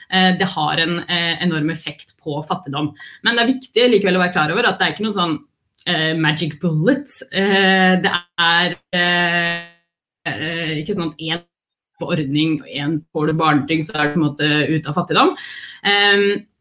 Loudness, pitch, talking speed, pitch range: -17 LUFS, 170 Hz, 190 wpm, 155-190 Hz